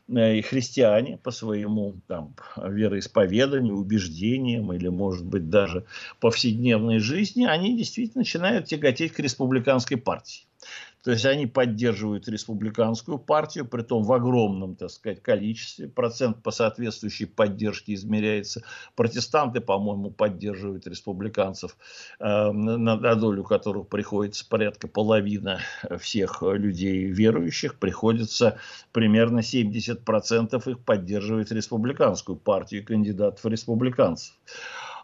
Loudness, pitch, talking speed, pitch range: -25 LUFS, 110 Hz, 105 wpm, 105-120 Hz